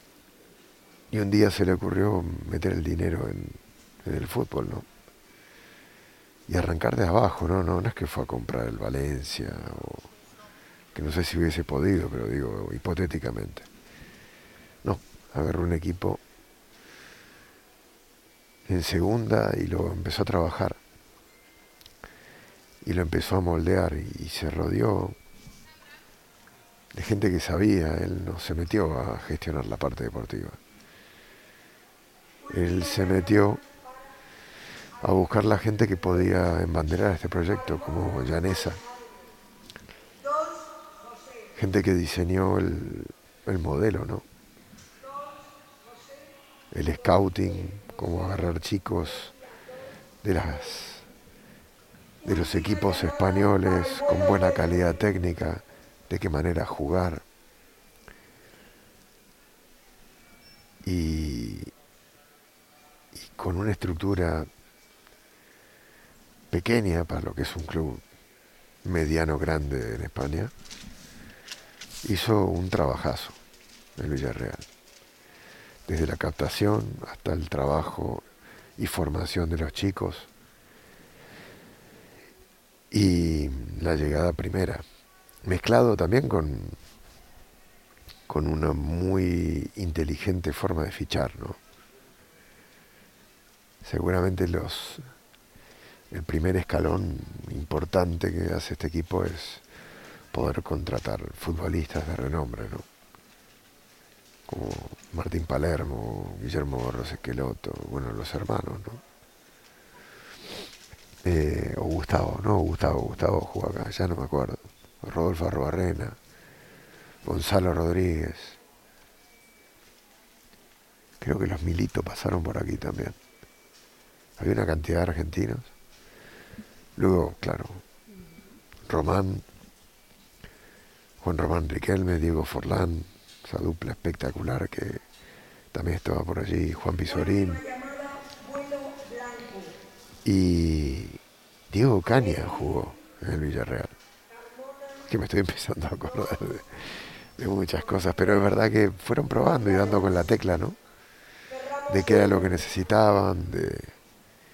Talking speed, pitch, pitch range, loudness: 105 wpm, 90 Hz, 80-105 Hz, -27 LUFS